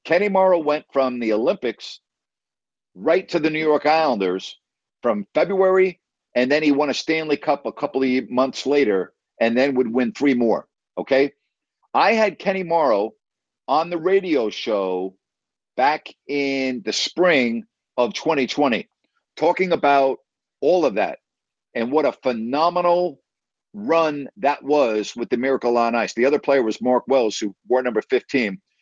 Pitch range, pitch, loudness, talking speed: 125-170 Hz, 145 Hz, -20 LUFS, 155 wpm